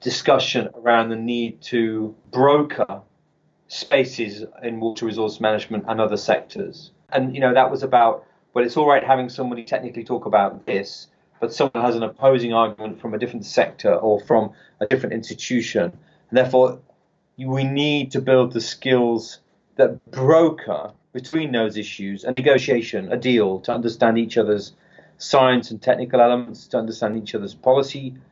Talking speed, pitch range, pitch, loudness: 160 wpm, 110-130 Hz, 120 Hz, -20 LUFS